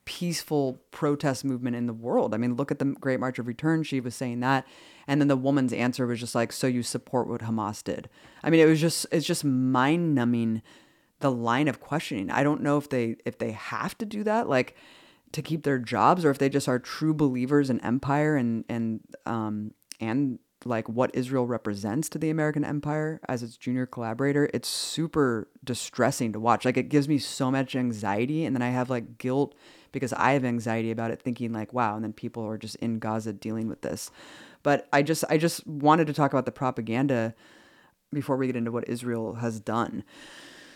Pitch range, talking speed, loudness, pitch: 120-145 Hz, 210 wpm, -27 LUFS, 130 Hz